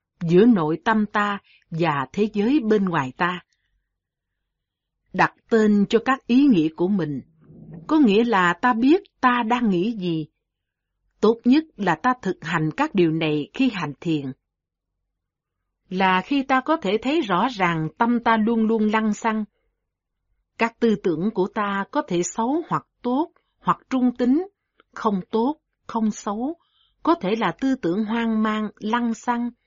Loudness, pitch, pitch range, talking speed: -22 LUFS, 215 Hz, 175-245 Hz, 160 wpm